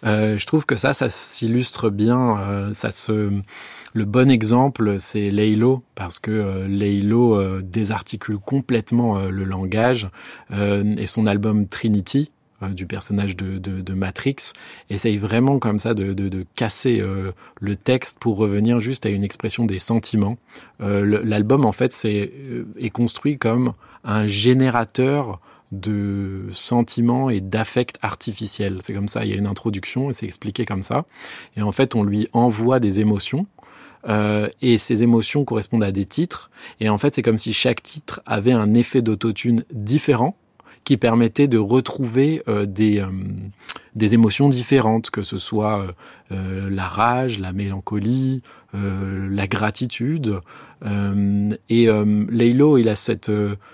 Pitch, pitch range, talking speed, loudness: 110 Hz, 100-120 Hz, 165 wpm, -20 LUFS